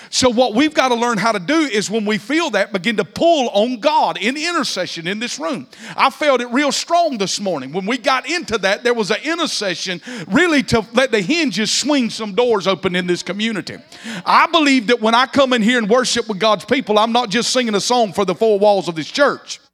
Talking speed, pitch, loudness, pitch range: 235 wpm, 235 Hz, -16 LUFS, 205-270 Hz